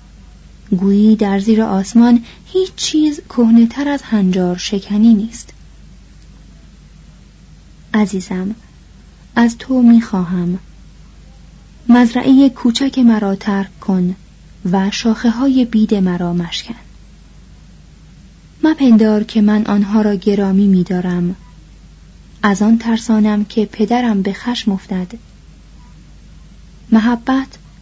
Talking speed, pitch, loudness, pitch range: 95 wpm, 215 Hz, -14 LUFS, 195-235 Hz